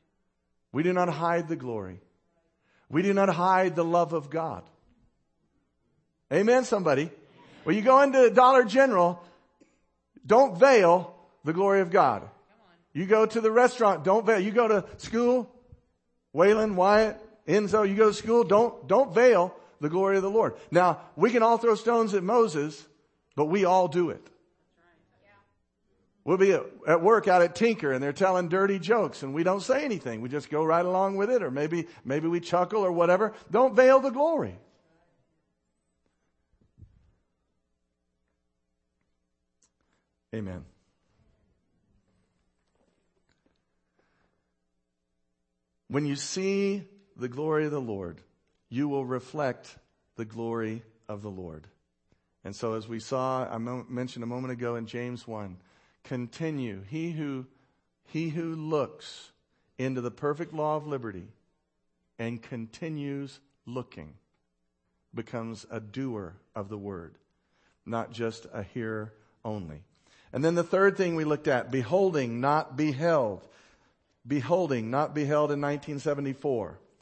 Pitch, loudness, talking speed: 145 Hz, -26 LUFS, 135 wpm